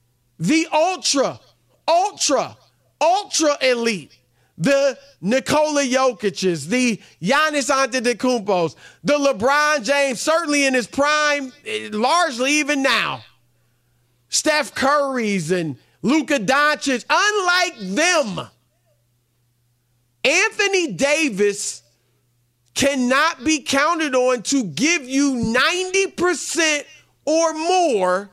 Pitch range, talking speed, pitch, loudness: 185-300 Hz, 85 wpm, 265 Hz, -19 LUFS